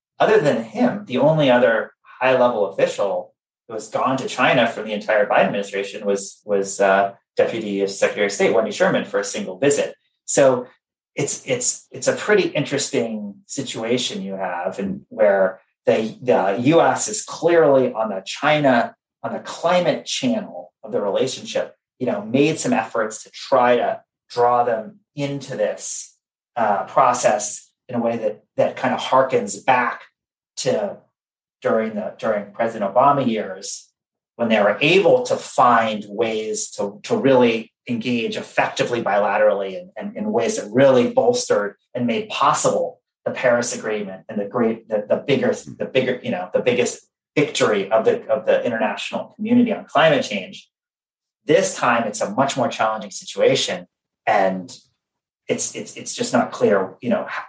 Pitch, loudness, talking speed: 165 Hz, -20 LUFS, 160 wpm